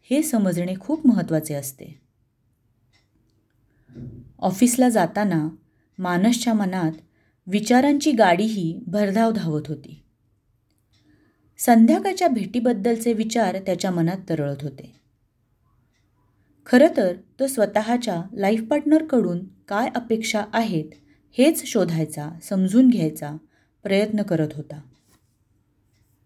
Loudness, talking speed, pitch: -21 LUFS, 85 wpm, 180 Hz